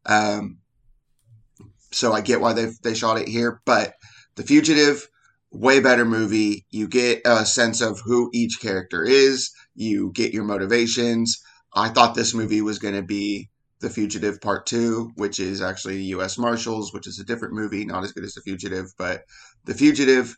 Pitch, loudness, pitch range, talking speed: 115 Hz, -21 LUFS, 105-120 Hz, 175 wpm